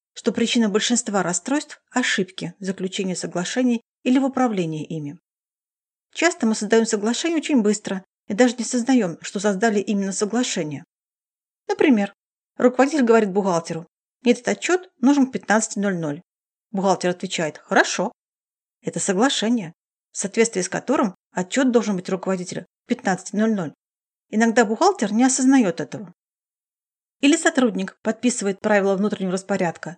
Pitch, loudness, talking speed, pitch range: 210 Hz, -21 LUFS, 125 wpm, 190-250 Hz